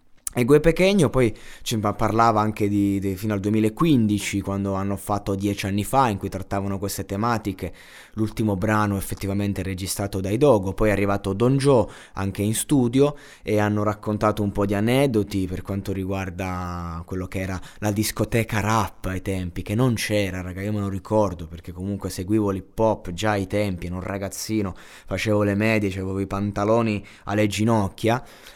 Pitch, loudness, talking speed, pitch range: 100 Hz, -23 LUFS, 170 wpm, 95-110 Hz